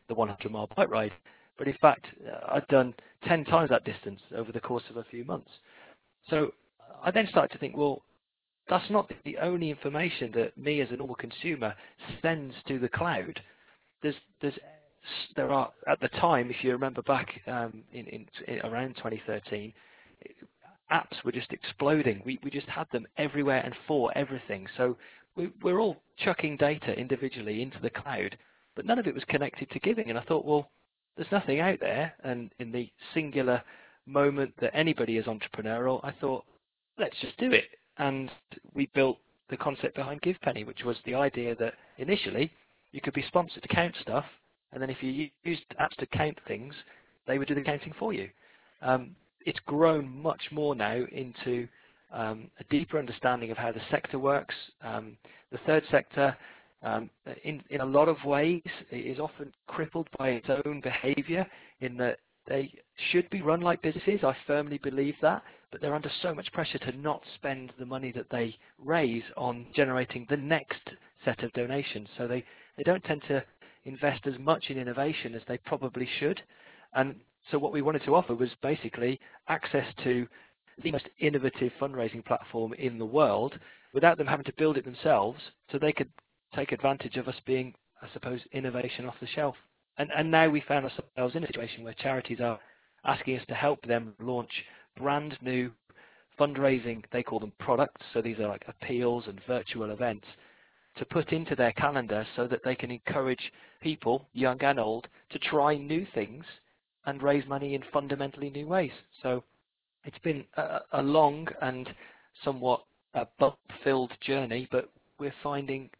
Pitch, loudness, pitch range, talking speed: 135 Hz, -31 LUFS, 125-145 Hz, 180 wpm